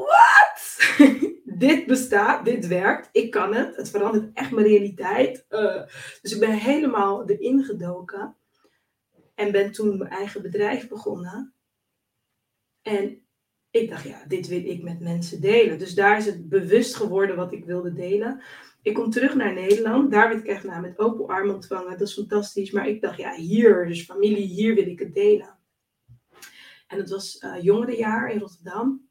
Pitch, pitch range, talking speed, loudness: 205 Hz, 195-235 Hz, 170 wpm, -22 LUFS